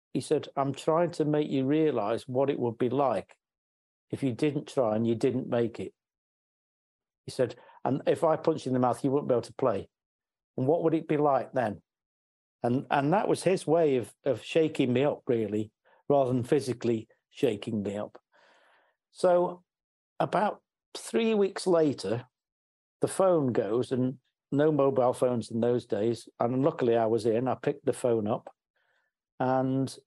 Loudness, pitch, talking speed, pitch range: -28 LUFS, 130 Hz, 180 wpm, 115-150 Hz